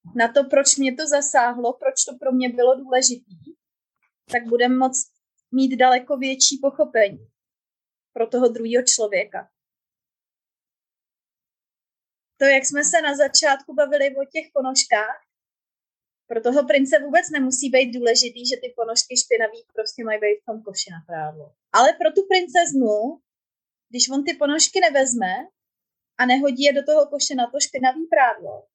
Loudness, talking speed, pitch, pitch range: -19 LUFS, 150 wpm, 260 Hz, 240-290 Hz